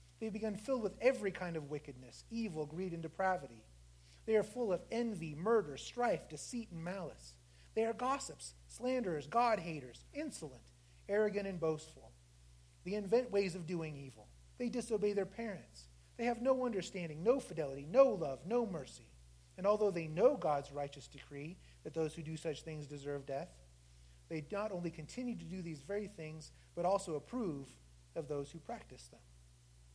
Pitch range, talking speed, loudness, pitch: 135-210 Hz, 165 wpm, -39 LUFS, 165 Hz